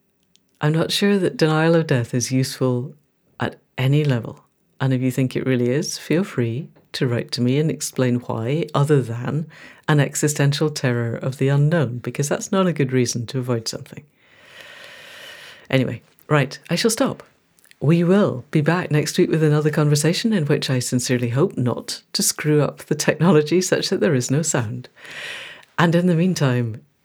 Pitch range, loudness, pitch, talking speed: 130-160 Hz, -20 LUFS, 145 Hz, 180 wpm